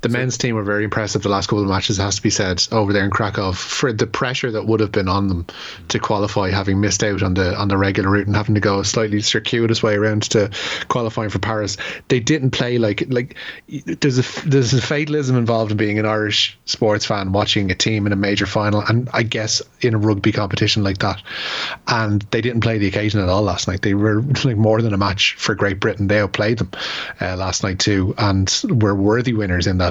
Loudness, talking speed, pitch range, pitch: -18 LUFS, 240 wpm, 100-115 Hz, 105 Hz